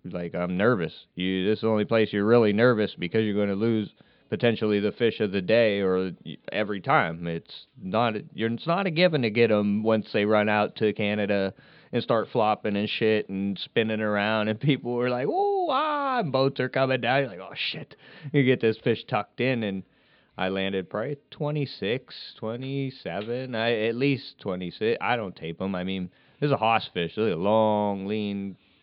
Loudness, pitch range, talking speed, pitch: -26 LUFS, 100-125 Hz, 195 wpm, 110 Hz